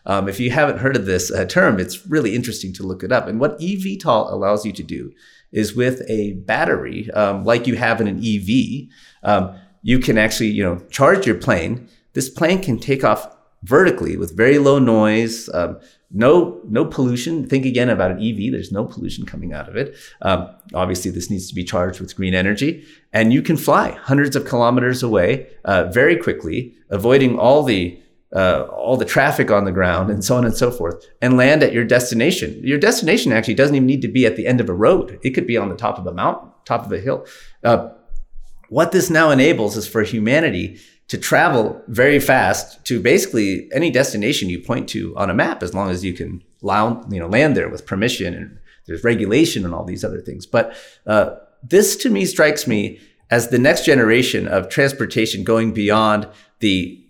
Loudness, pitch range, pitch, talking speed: -17 LUFS, 100-130 Hz, 115 Hz, 205 wpm